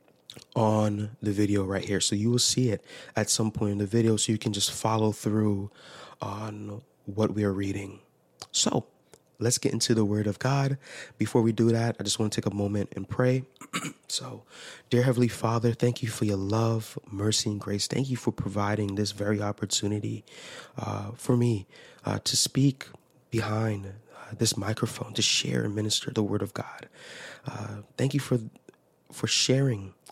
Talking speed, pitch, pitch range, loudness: 180 wpm, 110 Hz, 105-120 Hz, -27 LUFS